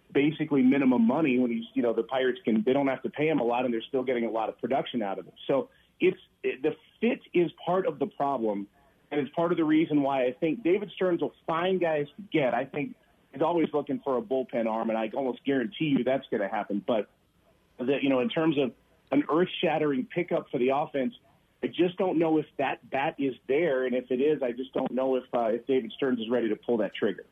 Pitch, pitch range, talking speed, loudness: 140 Hz, 125-165 Hz, 255 wpm, -28 LUFS